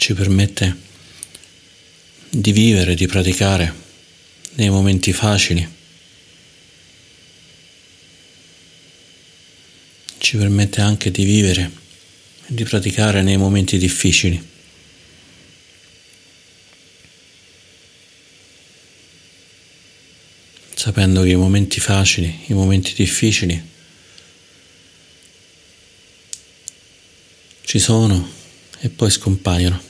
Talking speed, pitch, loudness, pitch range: 65 wpm, 95 Hz, -16 LUFS, 90-100 Hz